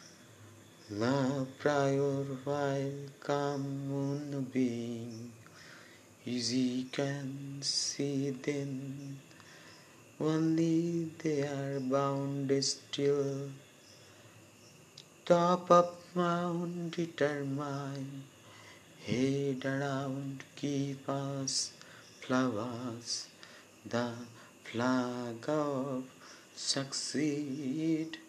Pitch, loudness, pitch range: 140 Hz, -34 LUFS, 130-145 Hz